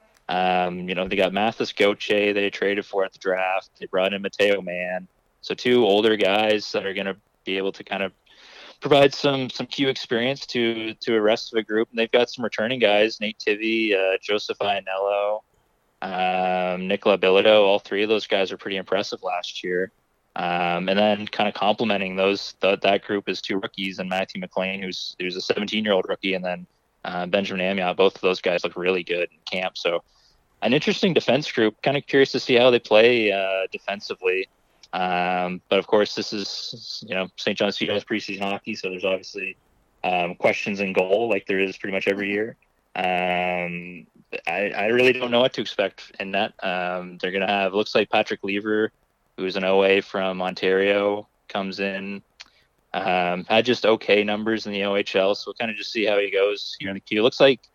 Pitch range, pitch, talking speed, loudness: 95-110 Hz, 100 Hz, 200 wpm, -23 LUFS